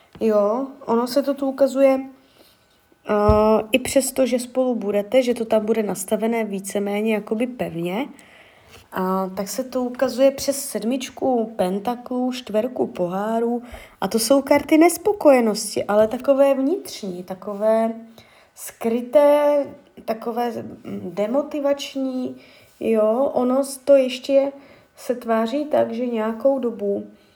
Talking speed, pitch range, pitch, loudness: 115 wpm, 215-275 Hz, 245 Hz, -21 LUFS